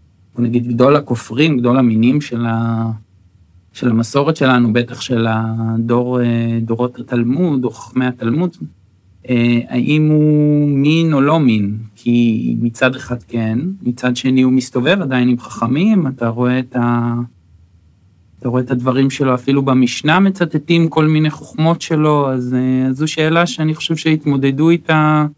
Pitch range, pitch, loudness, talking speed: 115-150 Hz, 125 Hz, -15 LUFS, 135 wpm